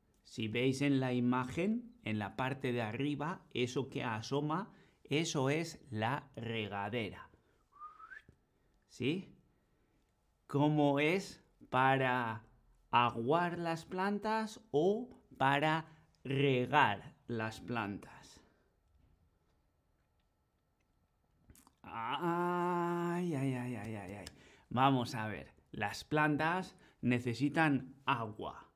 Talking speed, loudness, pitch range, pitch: 90 wpm, -35 LUFS, 110-160 Hz, 130 Hz